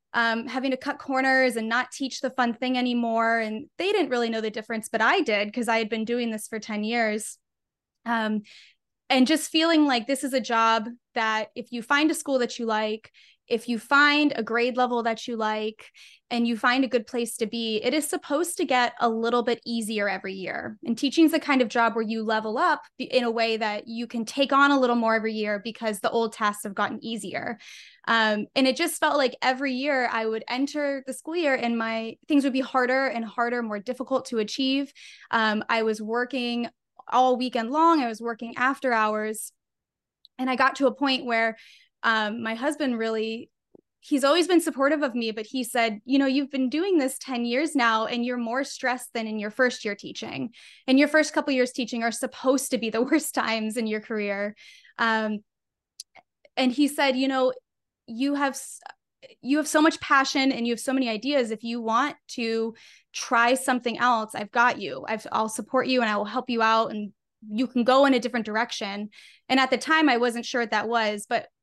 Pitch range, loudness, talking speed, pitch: 225-265 Hz, -25 LUFS, 215 wpm, 240 Hz